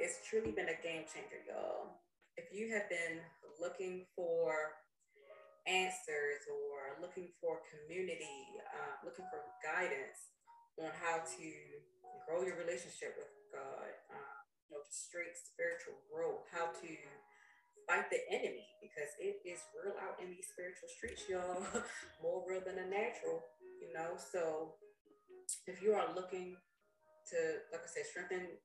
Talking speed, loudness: 145 wpm, -43 LUFS